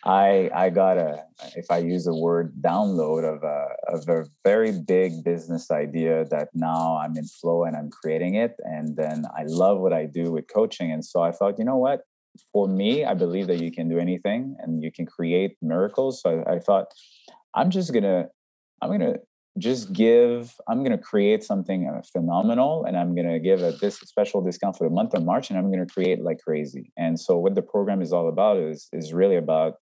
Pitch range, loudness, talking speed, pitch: 80-100 Hz, -24 LUFS, 220 wpm, 85 Hz